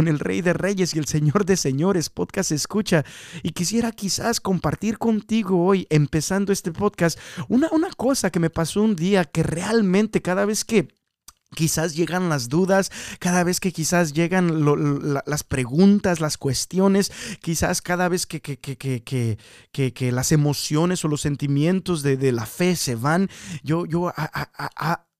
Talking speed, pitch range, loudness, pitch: 180 wpm, 150-190 Hz, -22 LUFS, 175 Hz